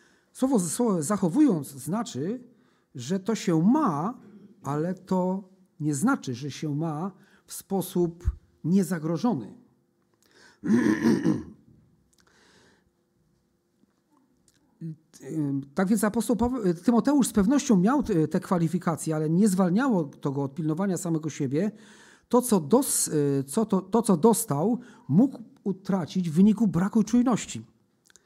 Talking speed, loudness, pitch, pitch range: 105 wpm, -26 LUFS, 190 Hz, 160-225 Hz